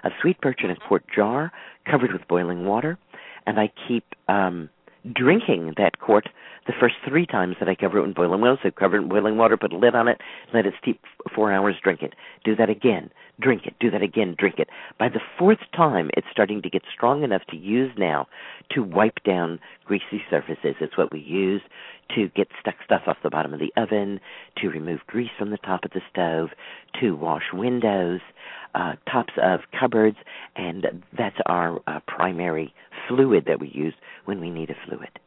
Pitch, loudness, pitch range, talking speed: 100 Hz, -23 LUFS, 90-115 Hz, 205 wpm